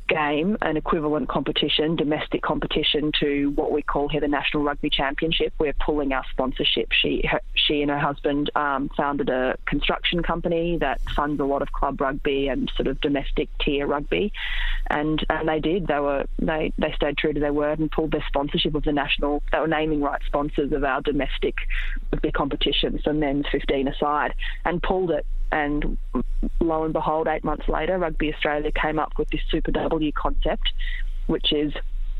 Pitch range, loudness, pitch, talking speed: 145-155 Hz, -24 LUFS, 150 Hz, 185 wpm